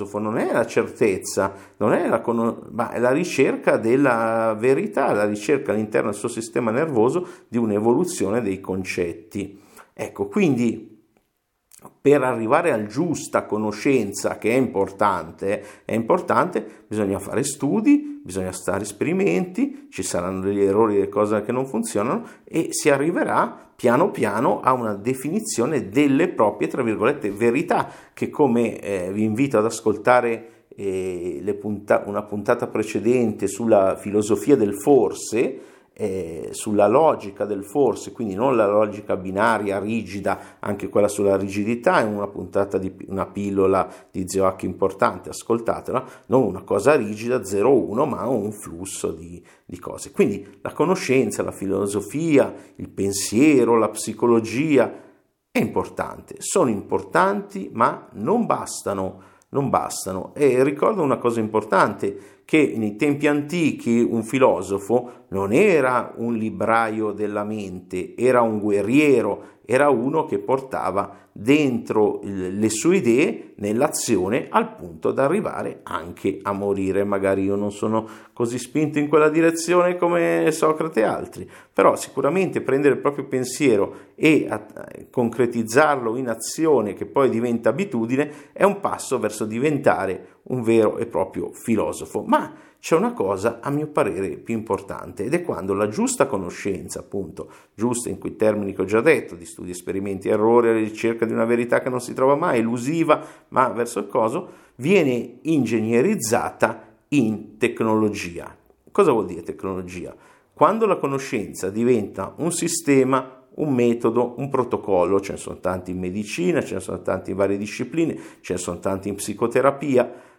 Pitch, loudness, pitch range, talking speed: 115 Hz, -22 LUFS, 100-130 Hz, 145 wpm